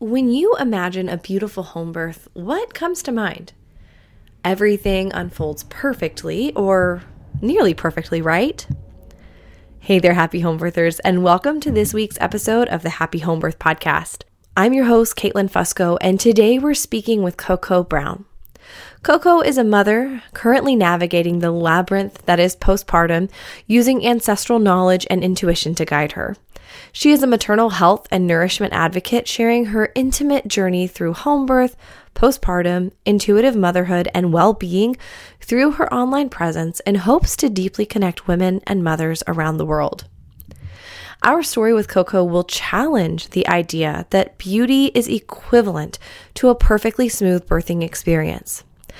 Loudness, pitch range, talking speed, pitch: -17 LUFS, 175-235 Hz, 145 wpm, 190 Hz